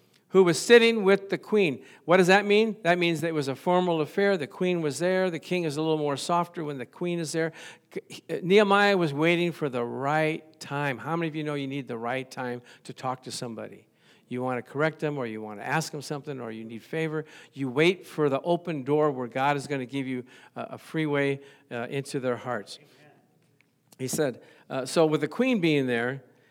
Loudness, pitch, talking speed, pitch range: -26 LUFS, 150 Hz, 220 wpm, 130-175 Hz